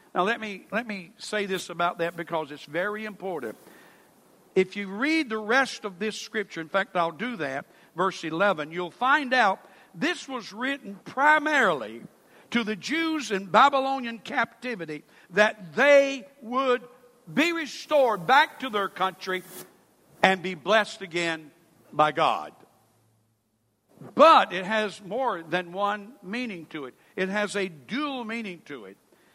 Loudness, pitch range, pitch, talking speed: -25 LUFS, 175-250 Hz, 205 Hz, 145 wpm